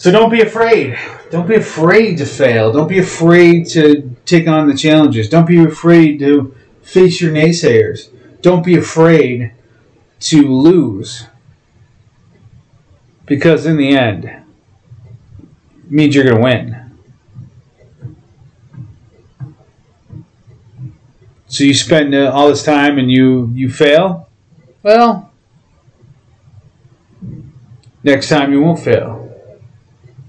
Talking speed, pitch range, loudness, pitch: 110 wpm, 120-160 Hz, -10 LUFS, 140 Hz